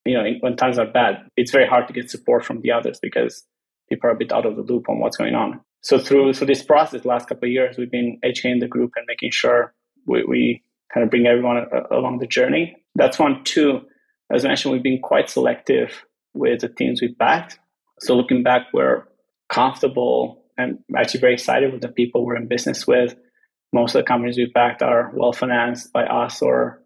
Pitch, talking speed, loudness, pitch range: 120 Hz, 215 wpm, -19 LUFS, 120-125 Hz